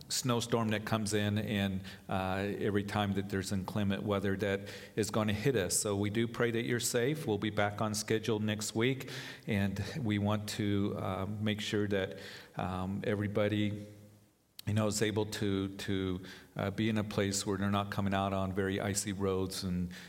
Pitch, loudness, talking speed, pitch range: 105 Hz, -34 LUFS, 200 wpm, 100-110 Hz